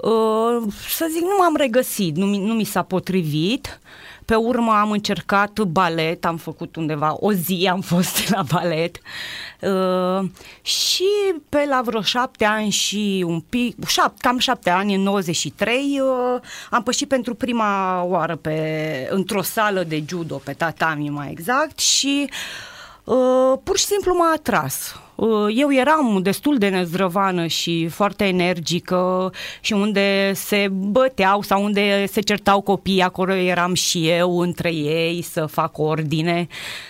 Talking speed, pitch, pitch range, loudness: 145 wpm, 195 Hz, 175-240 Hz, -20 LUFS